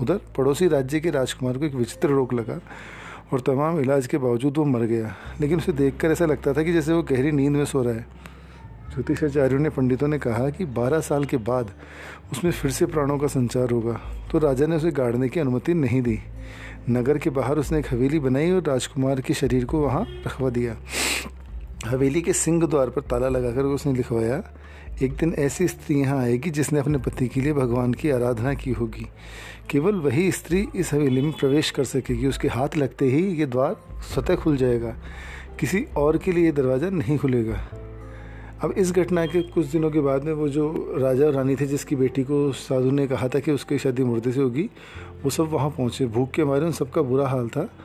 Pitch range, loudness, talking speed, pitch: 125-150 Hz, -23 LUFS, 205 wpm, 135 Hz